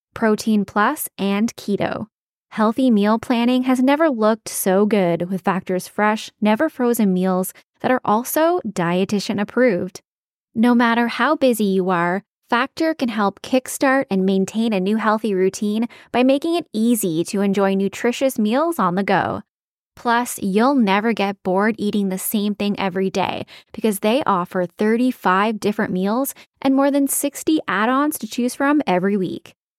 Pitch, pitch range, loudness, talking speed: 215 Hz, 195-250 Hz, -19 LUFS, 155 wpm